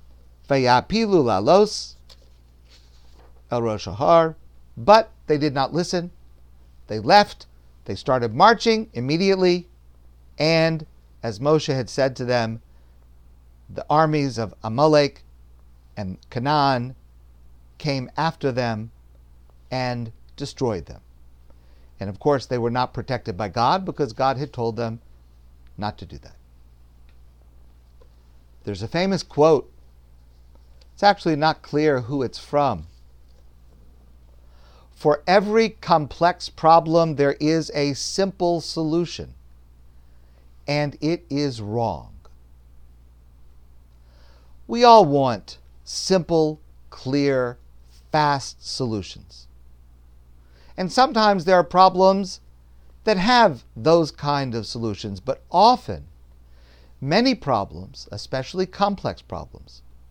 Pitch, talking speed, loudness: 110 Hz, 100 wpm, -21 LUFS